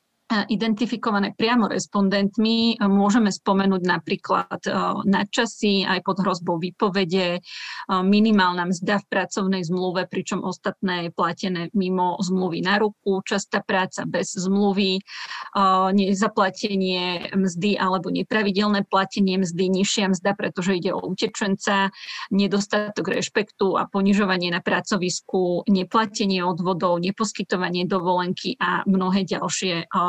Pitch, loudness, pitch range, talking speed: 195 Hz, -22 LUFS, 185-205 Hz, 105 wpm